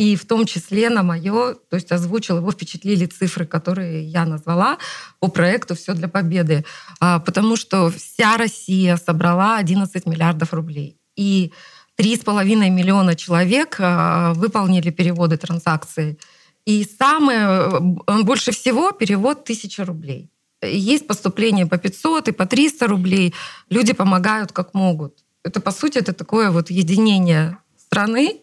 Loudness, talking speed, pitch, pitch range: -18 LUFS, 130 wpm, 185 Hz, 175-215 Hz